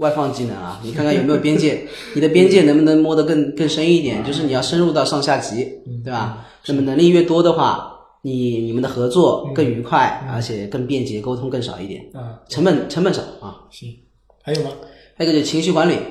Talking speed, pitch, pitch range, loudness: 325 characters per minute, 140 Hz, 120-155 Hz, -17 LUFS